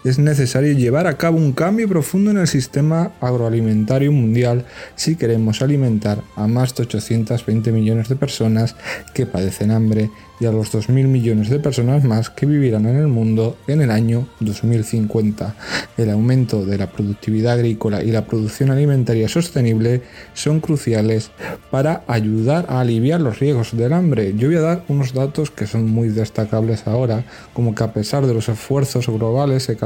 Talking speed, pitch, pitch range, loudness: 170 wpm, 120 Hz, 110-140 Hz, -18 LUFS